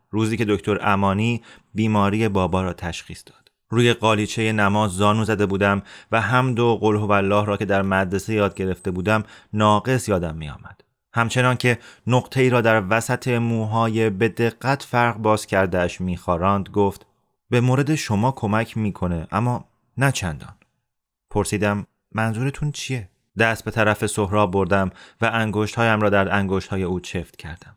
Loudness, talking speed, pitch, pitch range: -21 LUFS, 160 wpm, 105 Hz, 100-115 Hz